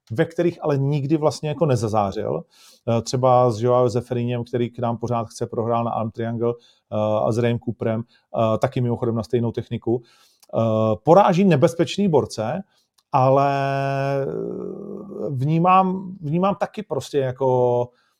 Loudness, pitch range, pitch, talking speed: -21 LUFS, 115-150 Hz, 125 Hz, 125 wpm